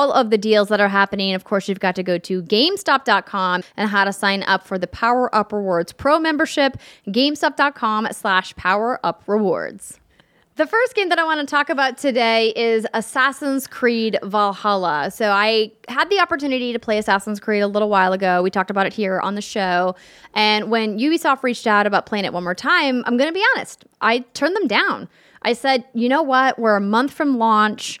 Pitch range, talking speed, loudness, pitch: 200-270 Hz, 205 wpm, -18 LUFS, 220 Hz